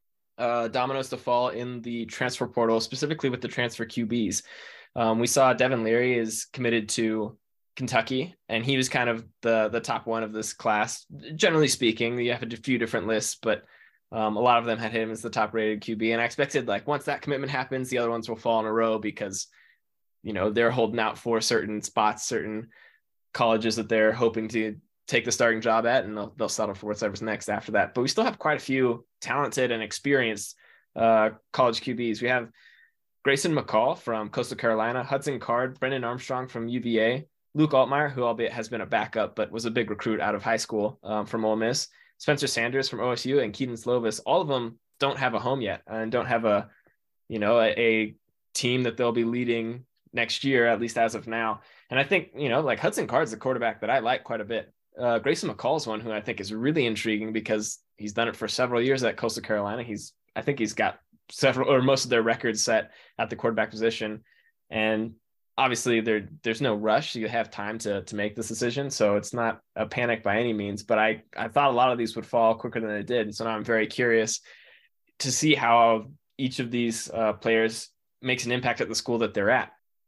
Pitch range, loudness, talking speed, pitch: 110-125 Hz, -26 LUFS, 220 wpm, 115 Hz